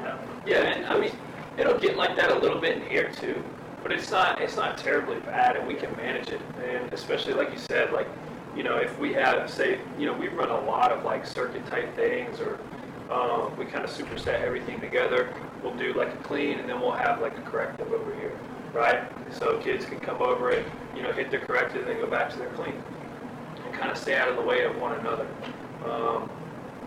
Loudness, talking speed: -28 LUFS, 230 wpm